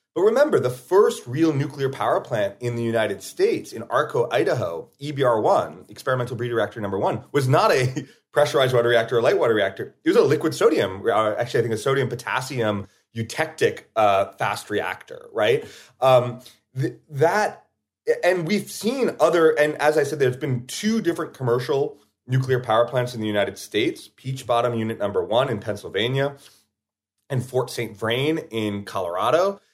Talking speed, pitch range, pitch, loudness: 170 wpm, 120-160 Hz, 130 Hz, -22 LUFS